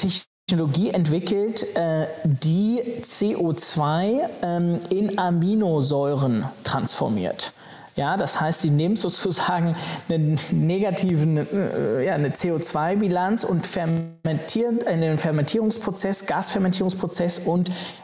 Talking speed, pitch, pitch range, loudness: 90 wpm, 175 Hz, 160-195 Hz, -22 LUFS